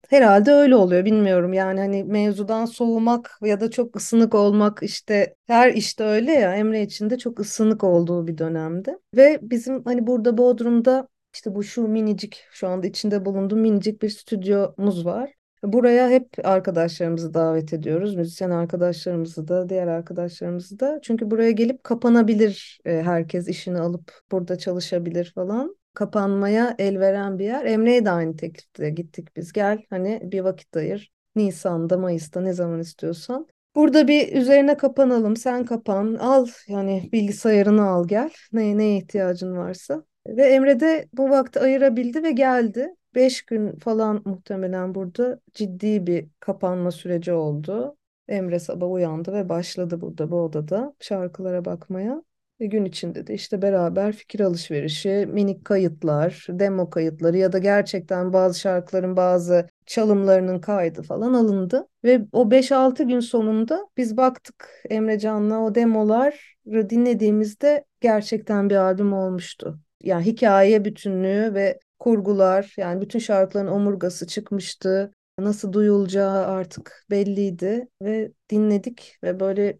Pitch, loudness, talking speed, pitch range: 205 Hz, -21 LUFS, 140 wpm, 185-230 Hz